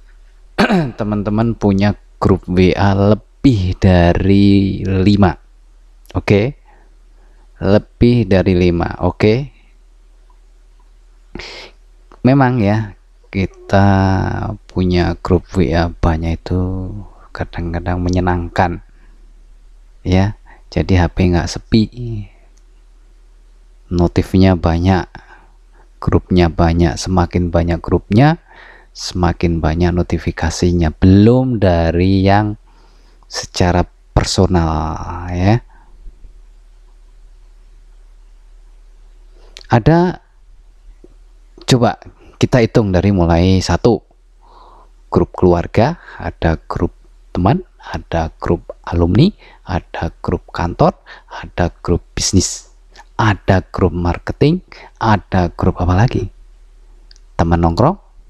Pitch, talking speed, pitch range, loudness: 95 Hz, 75 wpm, 85-105 Hz, -15 LUFS